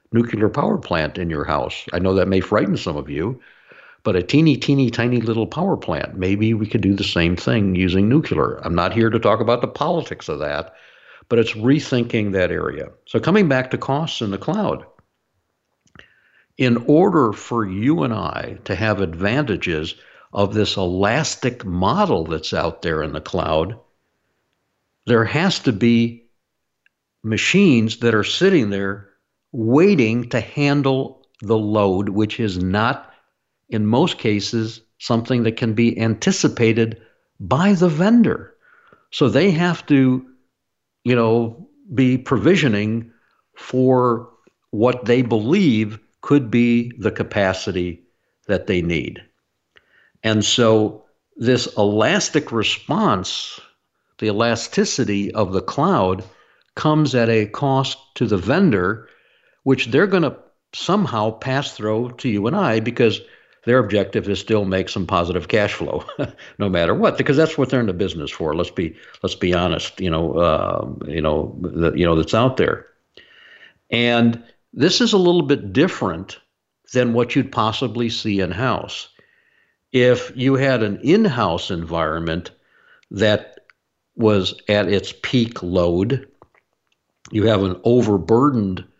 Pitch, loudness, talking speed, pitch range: 115 Hz, -19 LUFS, 145 wpm, 100-130 Hz